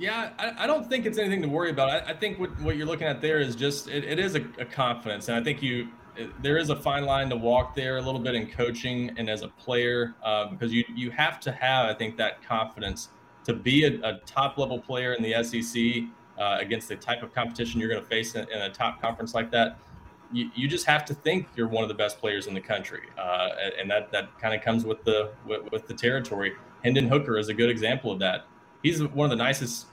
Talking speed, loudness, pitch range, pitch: 255 wpm, -27 LUFS, 115-145 Hz, 120 Hz